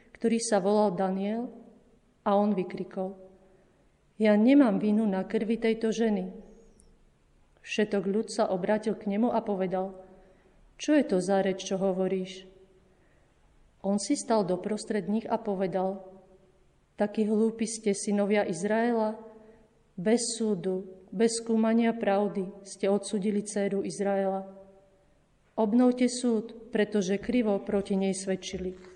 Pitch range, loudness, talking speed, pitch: 190-220 Hz, -28 LUFS, 120 wpm, 205 Hz